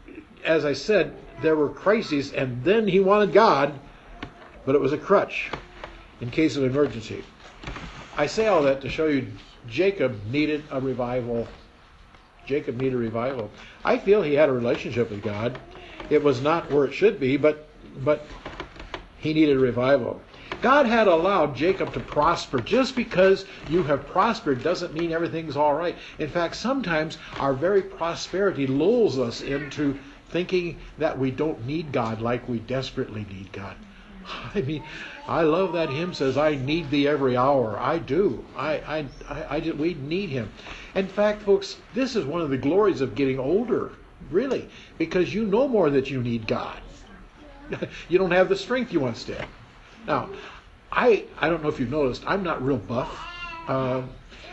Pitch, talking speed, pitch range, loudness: 145 Hz, 170 wpm, 130-175 Hz, -24 LUFS